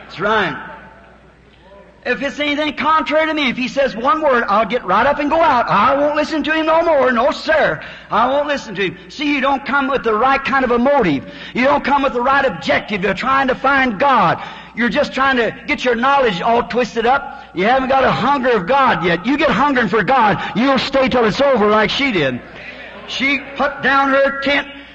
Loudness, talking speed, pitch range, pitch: -15 LUFS, 225 wpm, 240-285 Hz, 270 Hz